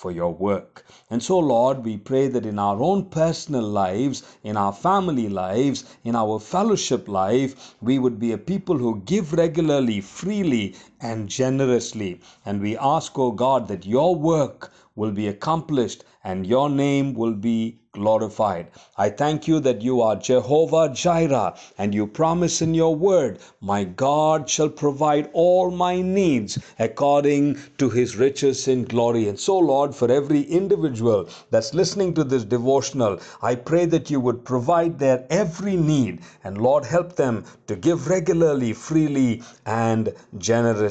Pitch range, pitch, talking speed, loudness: 115-160 Hz, 130 Hz, 155 wpm, -22 LUFS